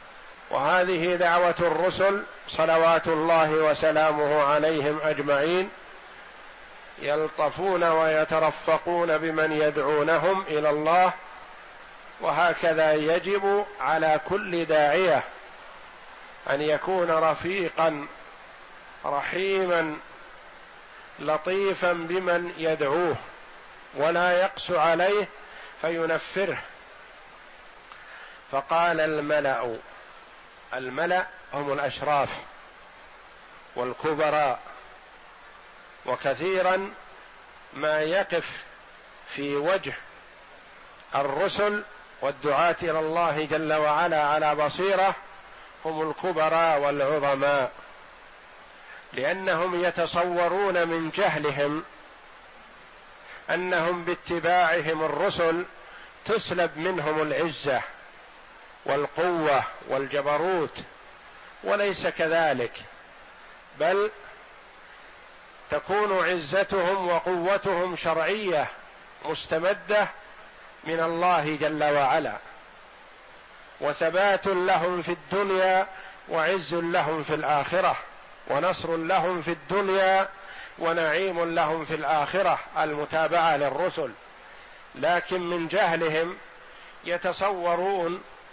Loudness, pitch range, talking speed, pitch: -25 LUFS, 155-180 Hz, 65 wpm, 165 Hz